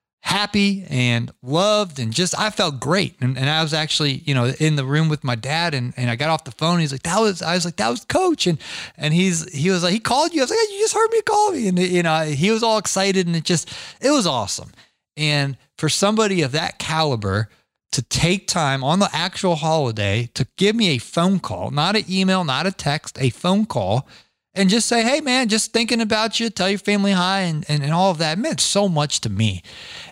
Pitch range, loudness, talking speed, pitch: 140-200 Hz, -19 LUFS, 240 wpm, 170 Hz